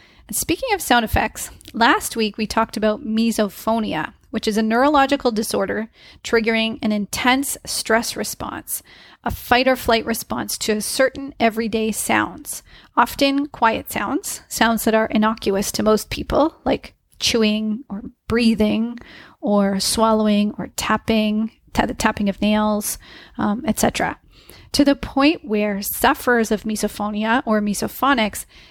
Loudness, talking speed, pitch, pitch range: -20 LUFS, 135 wpm, 225 Hz, 215-240 Hz